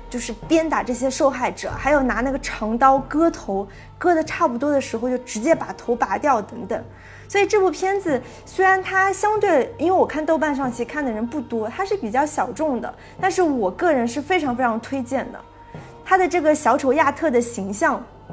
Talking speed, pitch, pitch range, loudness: 300 characters per minute, 280 Hz, 245-340 Hz, -21 LUFS